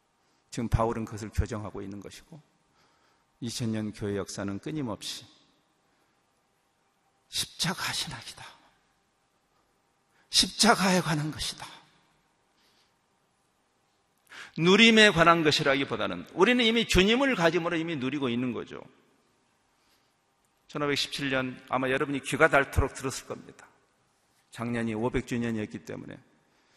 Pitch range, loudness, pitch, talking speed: 115-160 Hz, -26 LUFS, 135 Hz, 235 characters per minute